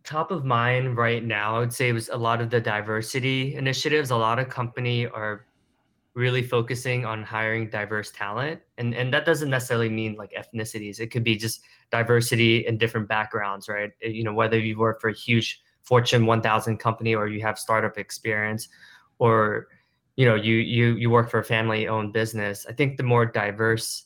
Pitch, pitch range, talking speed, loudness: 115 Hz, 110-120 Hz, 195 wpm, -24 LUFS